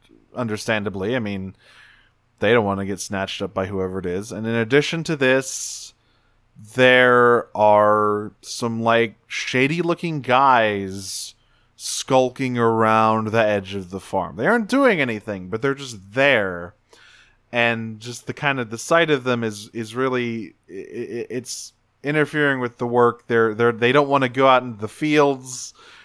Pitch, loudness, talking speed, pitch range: 120 Hz, -20 LUFS, 160 wpm, 110-130 Hz